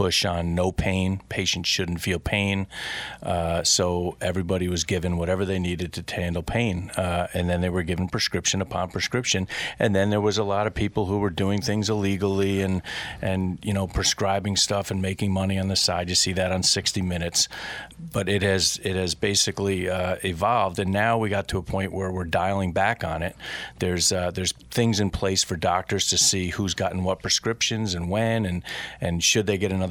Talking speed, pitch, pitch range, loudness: 205 wpm, 95 Hz, 90-100 Hz, -24 LUFS